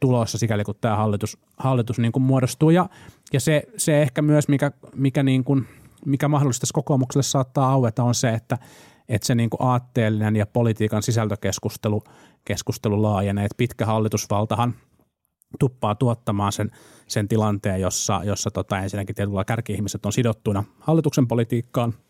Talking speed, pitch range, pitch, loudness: 145 wpm, 105-135 Hz, 120 Hz, -22 LUFS